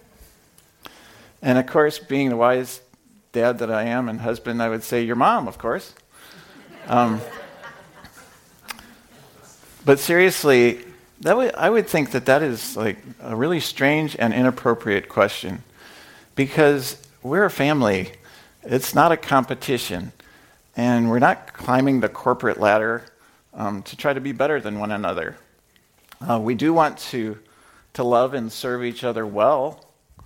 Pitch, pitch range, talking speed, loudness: 125 Hz, 115-140 Hz, 145 wpm, -21 LUFS